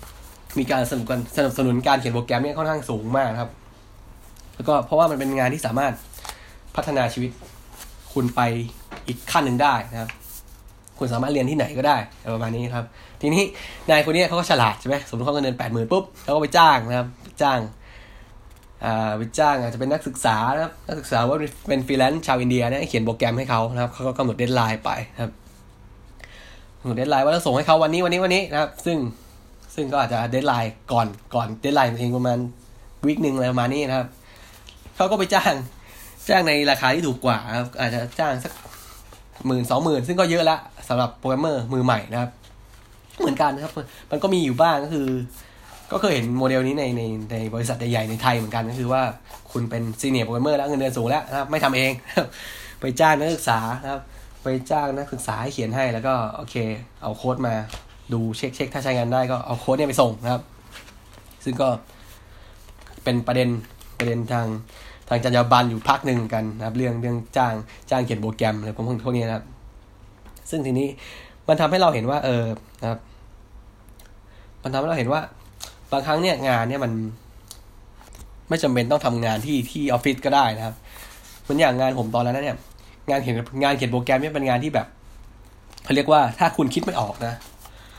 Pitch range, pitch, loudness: 110-135 Hz, 120 Hz, -22 LUFS